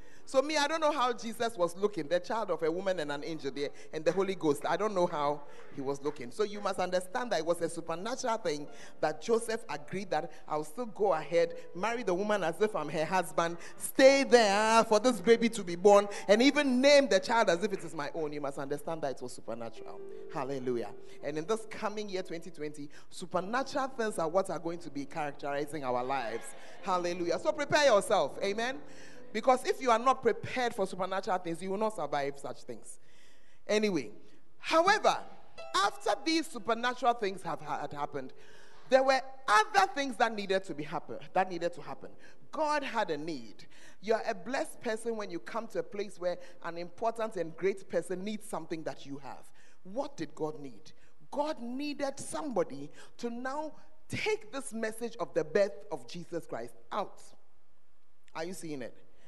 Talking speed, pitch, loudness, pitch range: 190 wpm, 195 Hz, -32 LUFS, 160-240 Hz